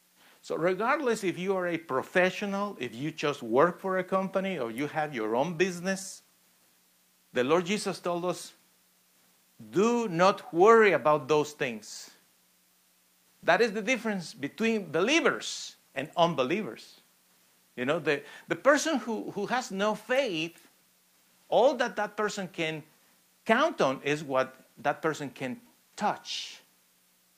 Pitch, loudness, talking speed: 165 Hz, -28 LUFS, 135 wpm